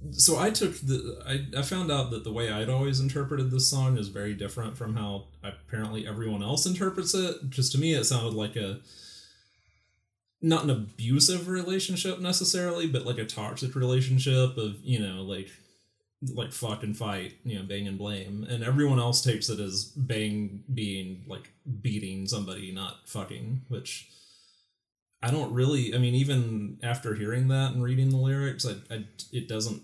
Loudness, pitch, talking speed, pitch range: -28 LUFS, 120 Hz, 175 wpm, 105-135 Hz